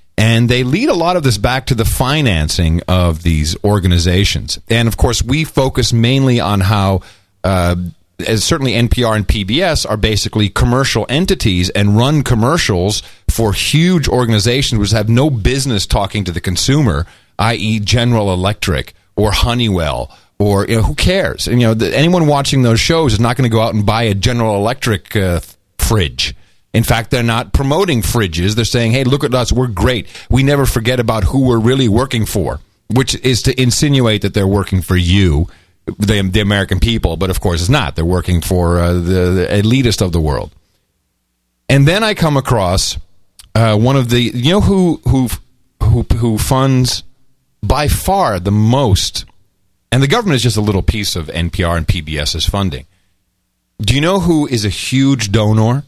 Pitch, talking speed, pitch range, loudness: 110 Hz, 185 wpm, 95-125 Hz, -13 LUFS